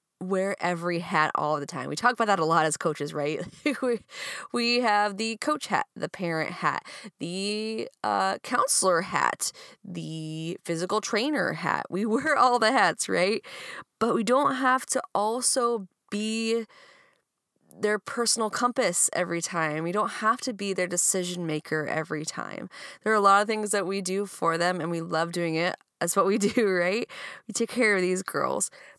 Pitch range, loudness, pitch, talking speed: 170-235 Hz, -26 LUFS, 200 Hz, 180 wpm